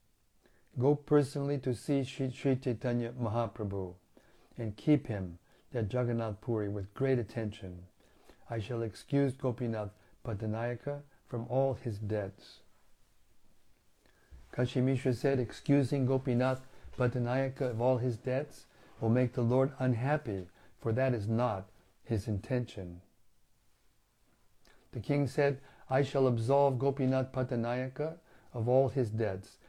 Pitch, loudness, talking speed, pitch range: 125 Hz, -33 LUFS, 115 wpm, 110-130 Hz